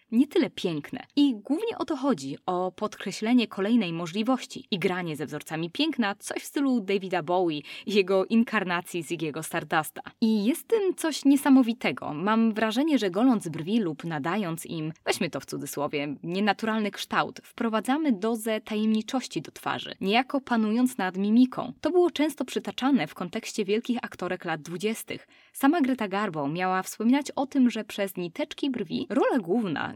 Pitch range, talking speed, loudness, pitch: 185-260 Hz, 155 wpm, -27 LUFS, 220 Hz